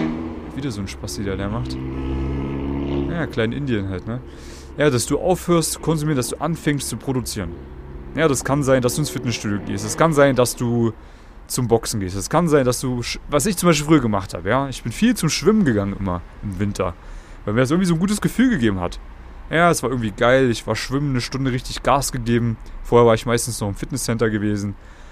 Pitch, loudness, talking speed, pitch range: 120 Hz, -20 LUFS, 225 wpm, 100-140 Hz